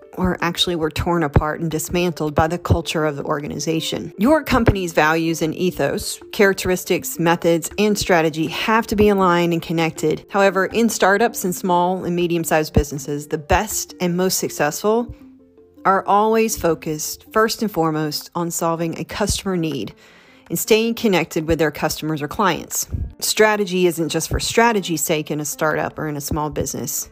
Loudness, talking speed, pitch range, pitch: -19 LUFS, 165 wpm, 160-195 Hz, 170 Hz